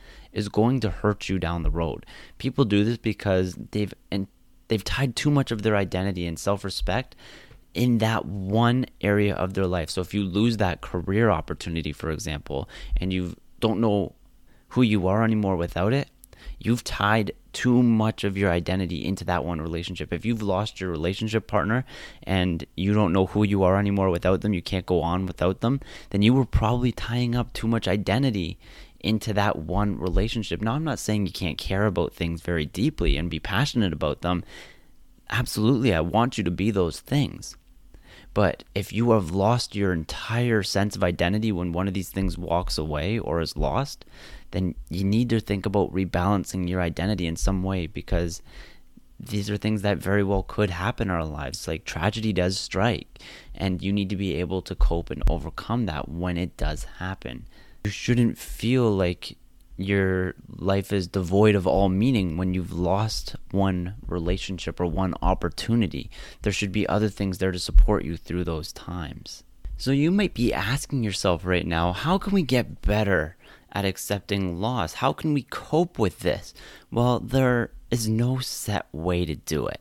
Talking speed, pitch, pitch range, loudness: 185 wpm, 95 Hz, 90-110 Hz, -25 LUFS